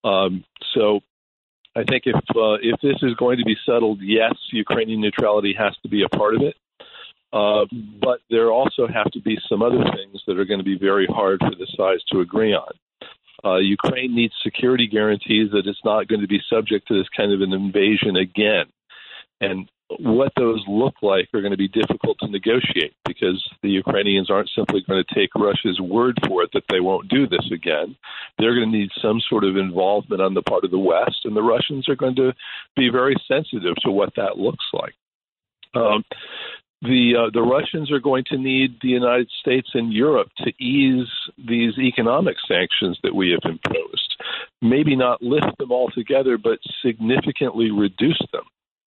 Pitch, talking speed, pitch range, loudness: 115 Hz, 190 wpm, 100-125 Hz, -20 LUFS